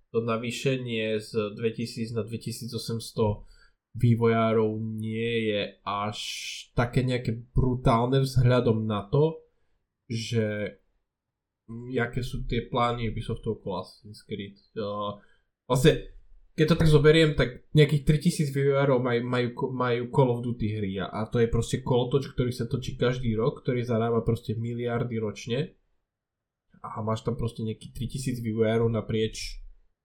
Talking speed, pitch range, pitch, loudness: 130 wpm, 110-125 Hz, 115 Hz, -27 LUFS